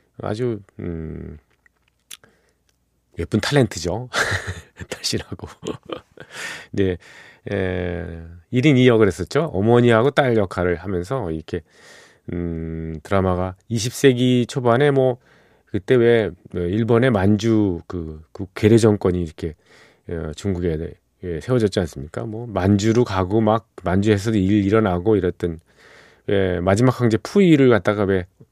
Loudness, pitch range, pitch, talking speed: -19 LUFS, 85-115 Hz, 100 Hz, 245 characters per minute